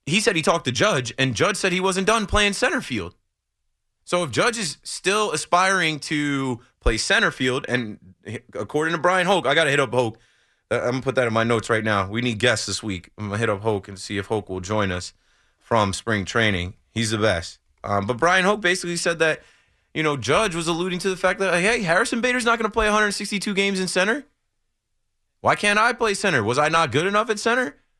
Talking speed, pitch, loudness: 225 wpm, 140 Hz, -21 LUFS